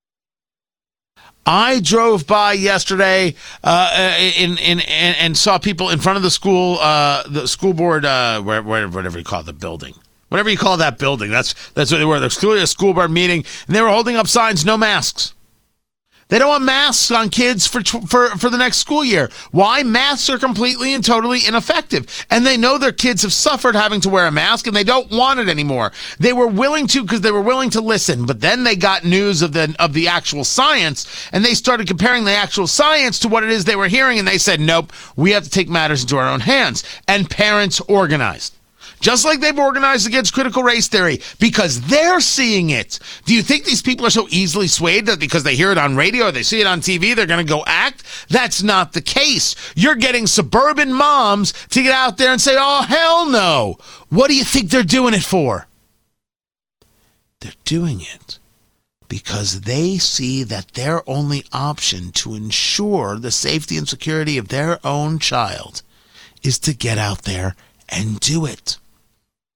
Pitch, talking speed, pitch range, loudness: 195 Hz, 205 wpm, 150-240 Hz, -15 LUFS